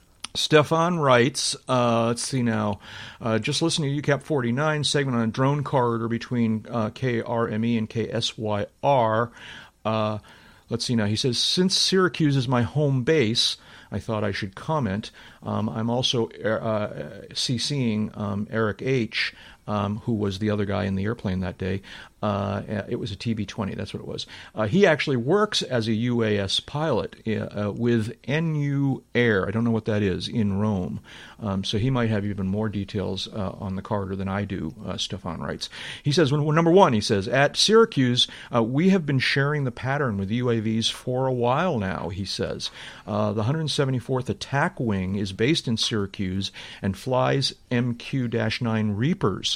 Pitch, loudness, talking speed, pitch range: 115 Hz, -24 LUFS, 180 wpm, 105-135 Hz